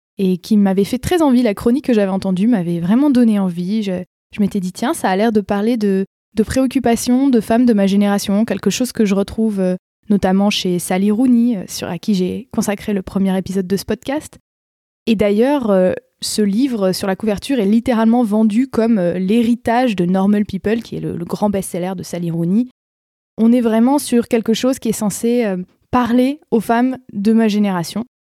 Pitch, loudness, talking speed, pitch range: 215 Hz, -16 LUFS, 195 wpm, 195-235 Hz